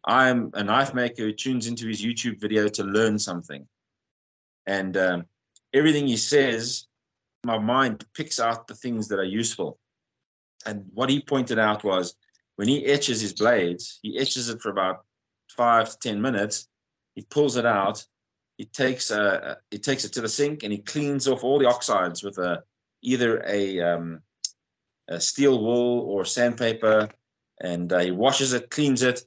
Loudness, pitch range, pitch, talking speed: -24 LUFS, 100-125 Hz, 115 Hz, 170 wpm